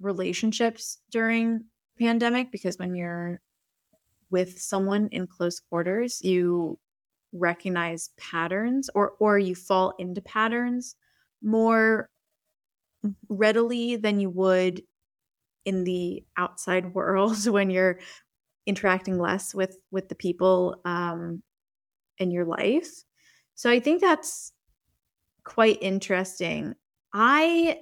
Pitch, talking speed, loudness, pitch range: 195 Hz, 105 wpm, -26 LUFS, 180-225 Hz